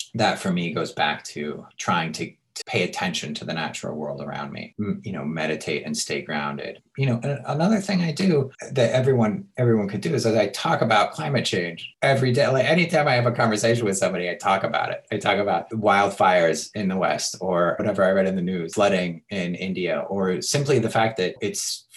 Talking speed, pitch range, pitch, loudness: 215 wpm, 95-140 Hz, 115 Hz, -23 LUFS